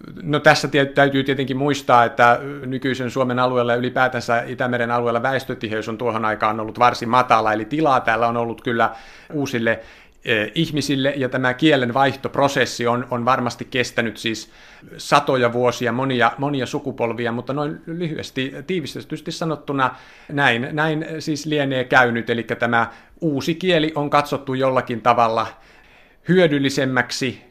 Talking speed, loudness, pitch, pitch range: 135 wpm, -20 LUFS, 130 Hz, 120-145 Hz